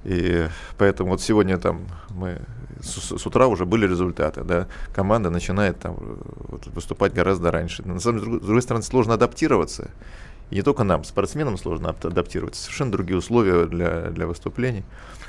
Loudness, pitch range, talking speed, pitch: -23 LUFS, 85-110 Hz, 160 wpm, 95 Hz